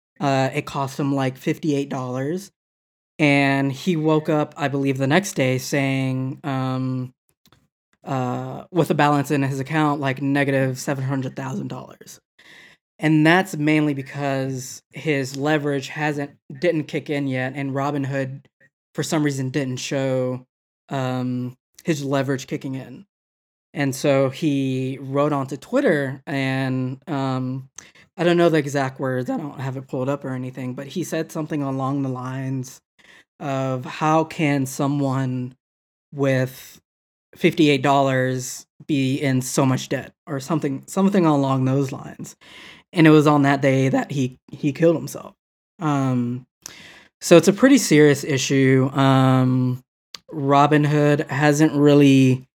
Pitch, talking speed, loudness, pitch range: 140 Hz, 145 wpm, -21 LUFS, 130-150 Hz